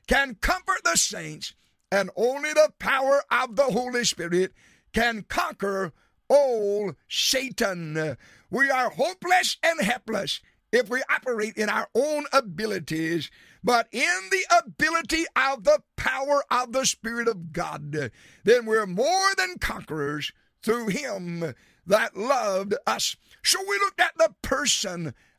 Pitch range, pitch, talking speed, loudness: 185-295 Hz, 235 Hz, 130 wpm, -24 LUFS